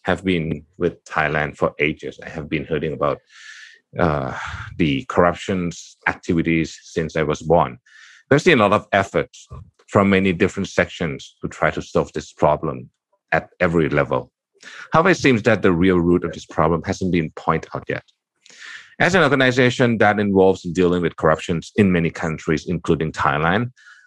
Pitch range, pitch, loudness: 80-100 Hz, 90 Hz, -19 LUFS